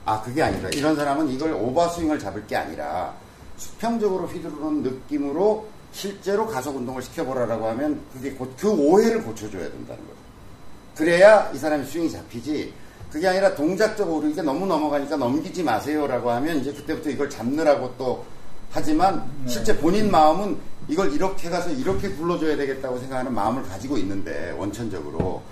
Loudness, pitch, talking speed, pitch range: -23 LUFS, 150 Hz, 410 characters per minute, 125-175 Hz